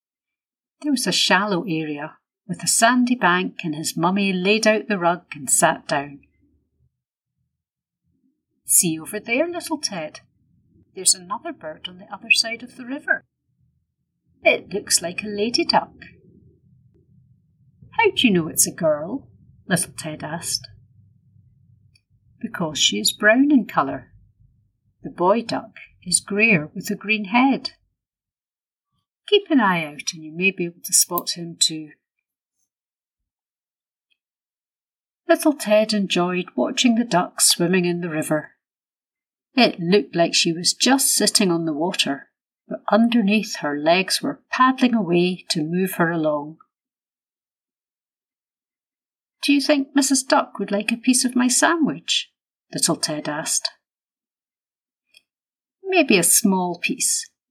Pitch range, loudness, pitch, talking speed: 165-245 Hz, -19 LUFS, 195 Hz, 135 wpm